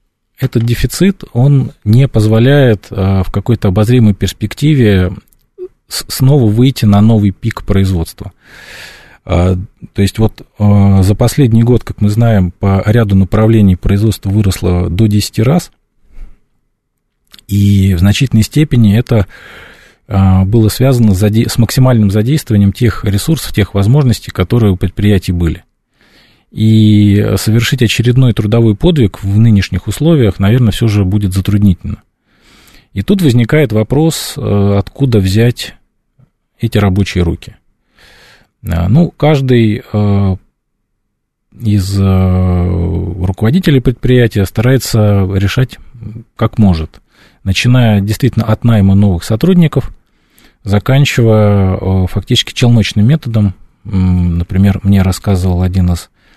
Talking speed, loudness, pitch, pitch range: 110 wpm, -11 LUFS, 105 Hz, 95-120 Hz